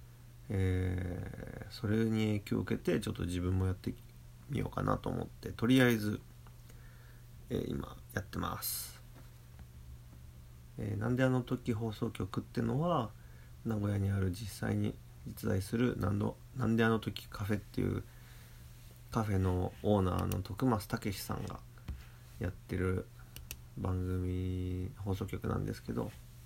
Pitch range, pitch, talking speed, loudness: 90-120 Hz, 110 Hz, 260 characters per minute, -36 LUFS